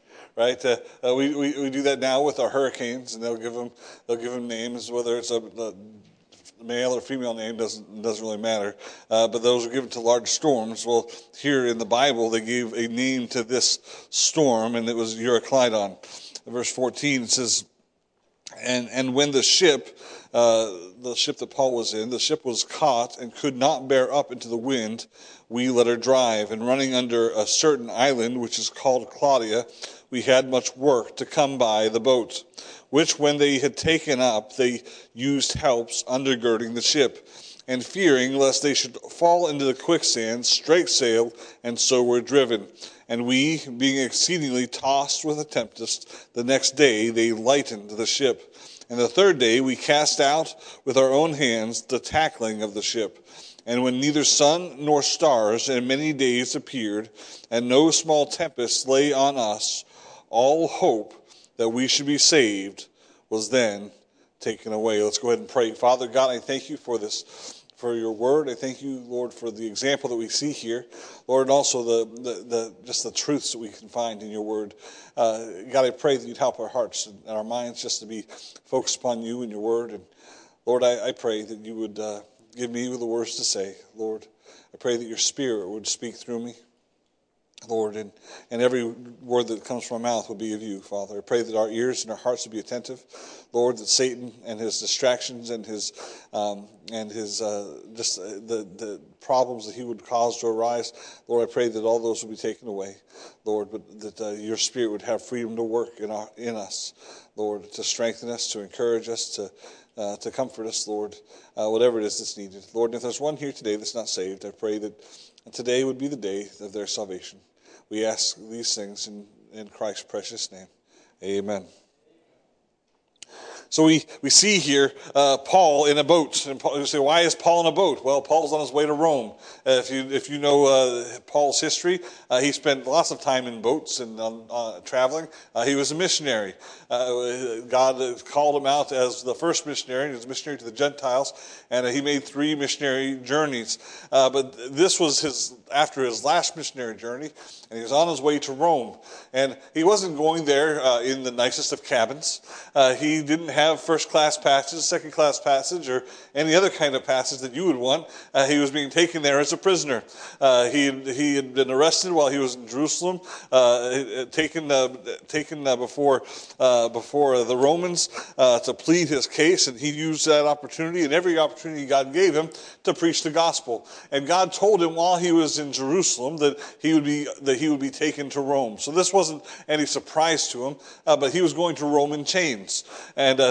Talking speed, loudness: 200 wpm, -23 LUFS